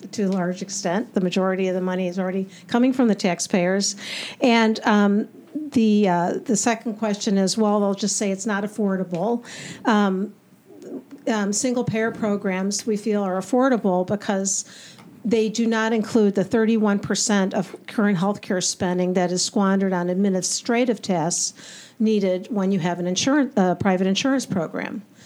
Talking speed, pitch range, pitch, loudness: 155 wpm, 190-225 Hz, 205 Hz, -22 LUFS